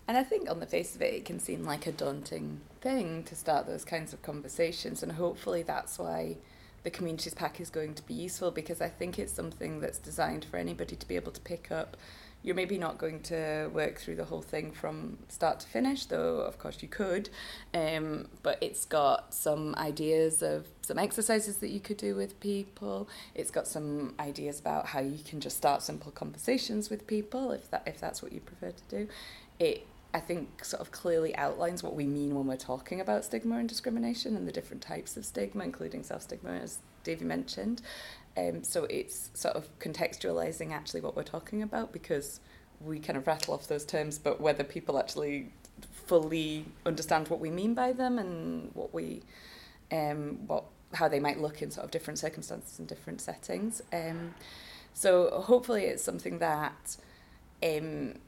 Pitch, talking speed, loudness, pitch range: 165 Hz, 195 wpm, -34 LUFS, 145-210 Hz